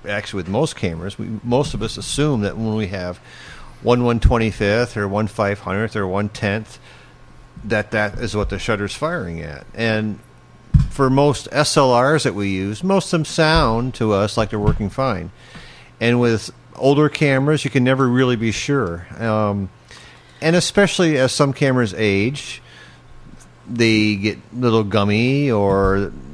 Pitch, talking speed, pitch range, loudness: 110 Hz, 150 wpm, 100-130 Hz, -19 LUFS